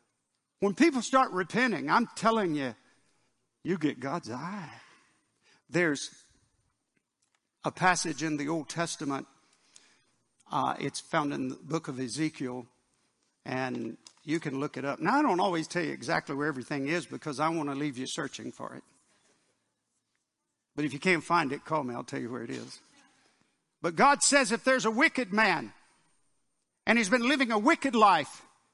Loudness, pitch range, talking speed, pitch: -29 LUFS, 140-220 Hz, 165 wpm, 160 Hz